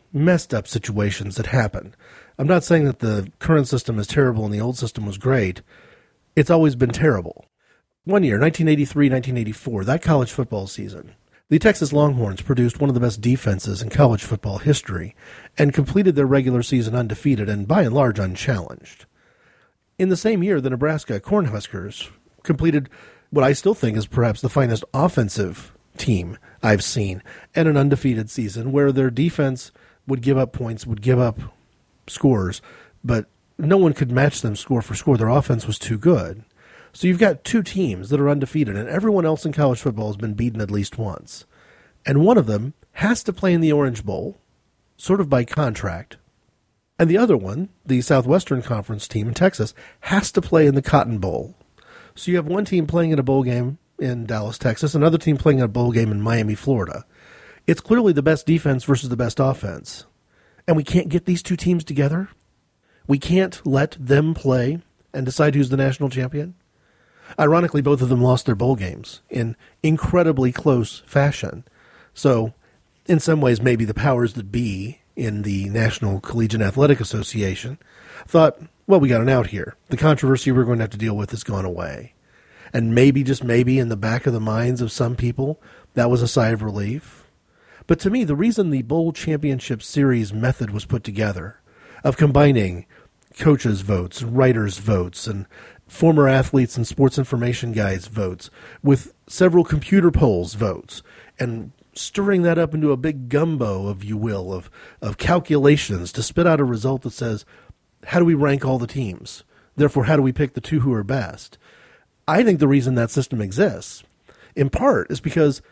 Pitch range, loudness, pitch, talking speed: 110-150 Hz, -20 LUFS, 130 Hz, 185 wpm